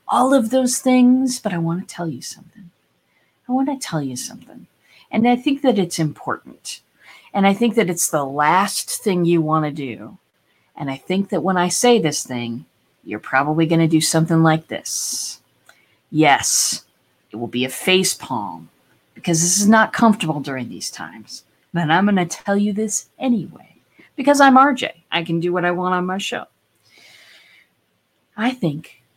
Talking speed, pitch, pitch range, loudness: 180 wpm, 180 Hz, 160-225 Hz, -18 LUFS